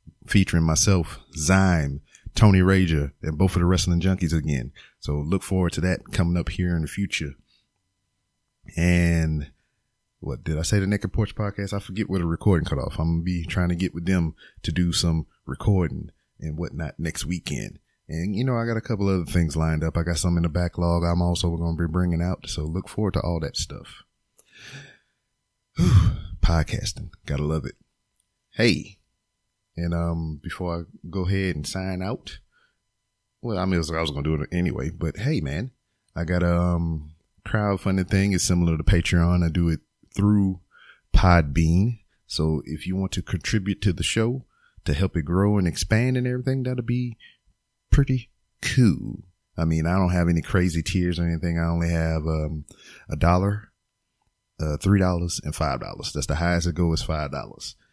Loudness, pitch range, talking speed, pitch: -24 LUFS, 80-100 Hz, 185 wpm, 90 Hz